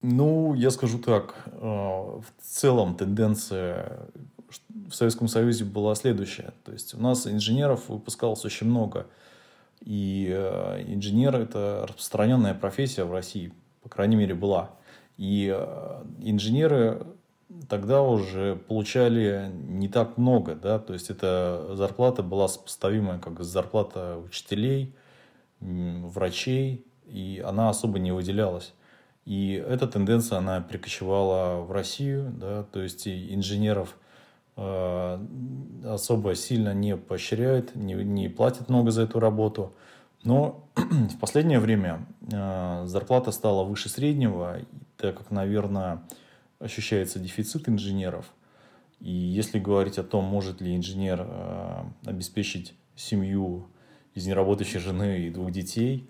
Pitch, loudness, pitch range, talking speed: 105 Hz, -27 LUFS, 95-120 Hz, 120 wpm